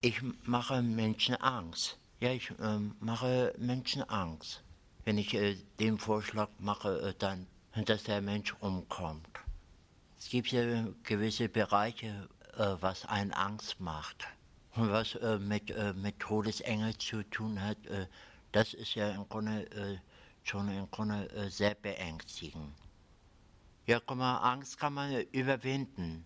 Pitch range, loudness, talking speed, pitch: 95-115 Hz, -35 LUFS, 145 wpm, 105 Hz